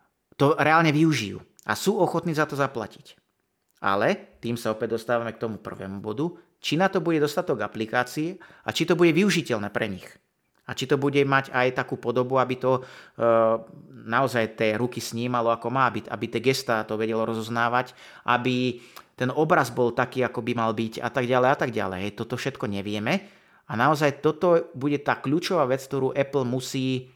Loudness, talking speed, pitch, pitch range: -25 LUFS, 190 wpm, 125 Hz, 115-145 Hz